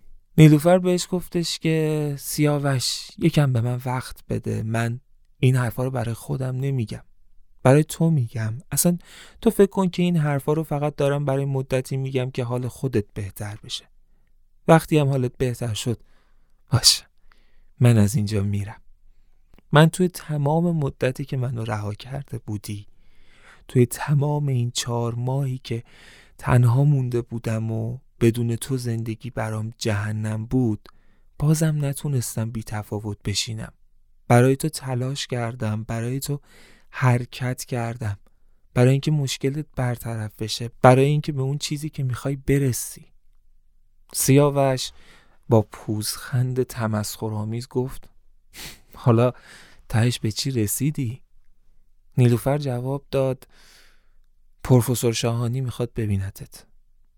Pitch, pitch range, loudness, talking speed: 125 Hz, 110-140 Hz, -23 LUFS, 125 wpm